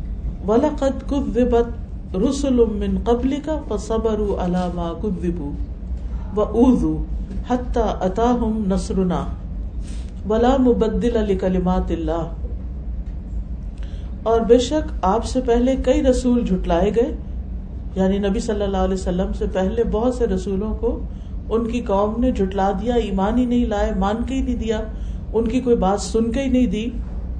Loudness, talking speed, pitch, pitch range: -21 LUFS, 140 wpm, 215 Hz, 185-240 Hz